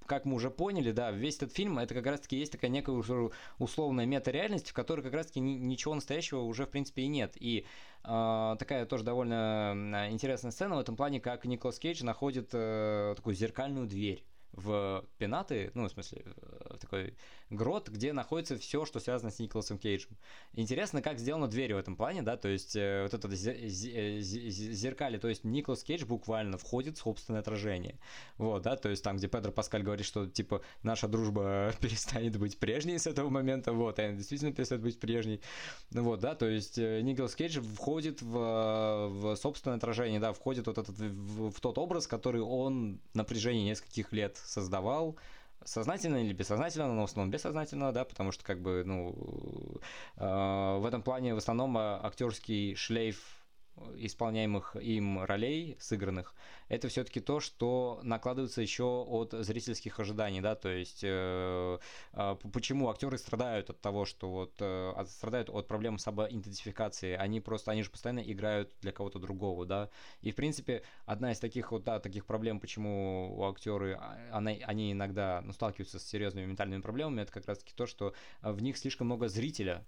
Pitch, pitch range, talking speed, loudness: 110 Hz, 105-125 Hz, 170 wpm, -36 LUFS